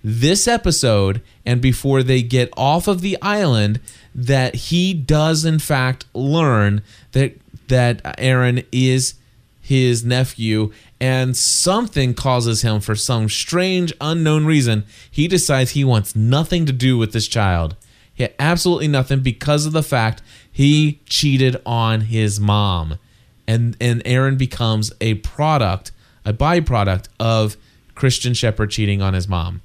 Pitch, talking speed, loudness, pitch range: 125 Hz, 140 wpm, -17 LUFS, 110-140 Hz